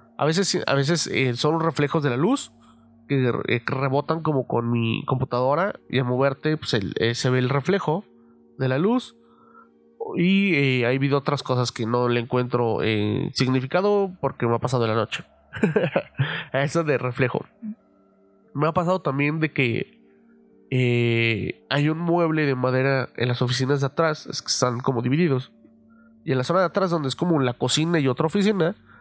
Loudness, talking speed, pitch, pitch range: -23 LUFS, 185 wpm, 135 Hz, 120-160 Hz